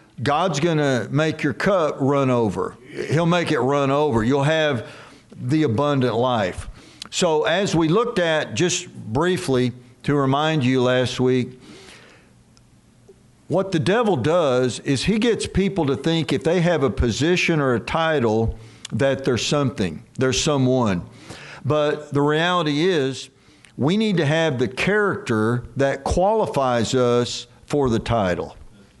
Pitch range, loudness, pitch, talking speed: 125-160 Hz, -21 LUFS, 140 Hz, 145 wpm